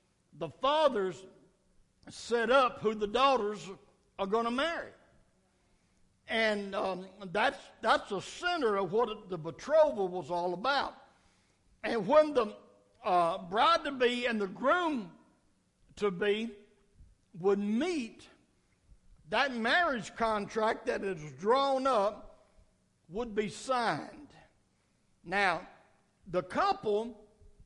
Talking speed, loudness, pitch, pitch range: 110 wpm, -31 LUFS, 220 Hz, 195-265 Hz